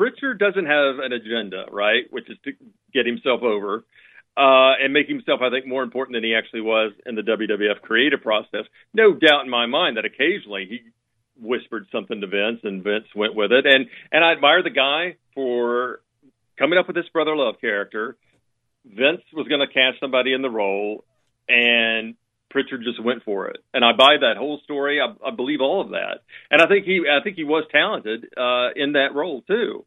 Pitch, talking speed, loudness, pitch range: 130 Hz, 205 wpm, -20 LUFS, 115-150 Hz